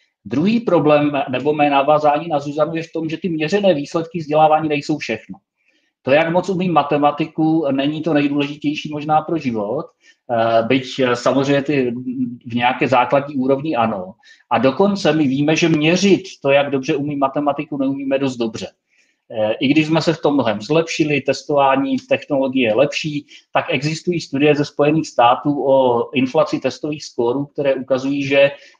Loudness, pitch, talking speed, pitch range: -17 LUFS, 145 Hz, 155 wpm, 135-155 Hz